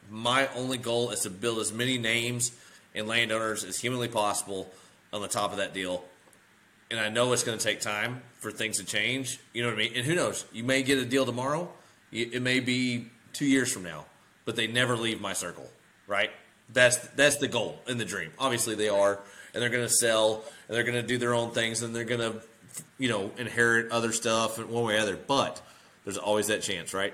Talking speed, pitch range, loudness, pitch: 220 wpm, 105-125 Hz, -28 LUFS, 115 Hz